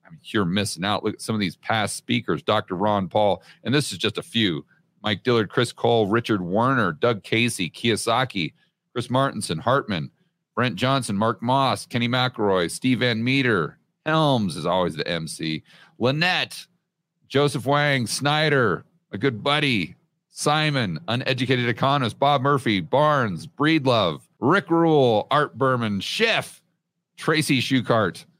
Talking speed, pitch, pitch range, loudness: 145 wpm, 130 Hz, 110-150 Hz, -22 LUFS